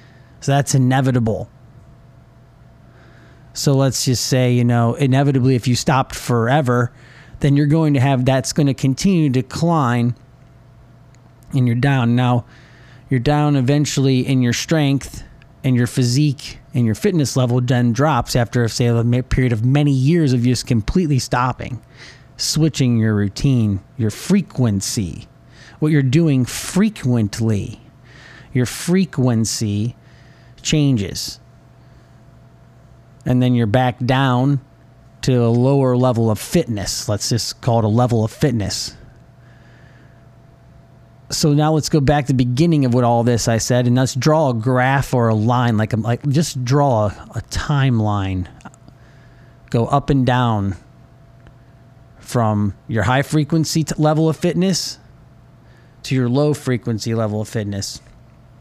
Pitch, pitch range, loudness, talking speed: 130 Hz, 120-140 Hz, -17 LUFS, 135 wpm